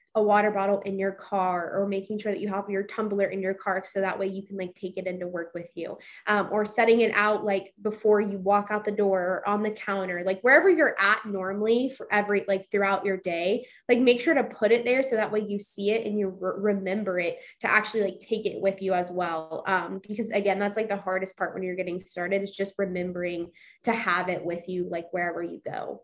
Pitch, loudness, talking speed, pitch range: 195 Hz, -26 LUFS, 245 wpm, 185-210 Hz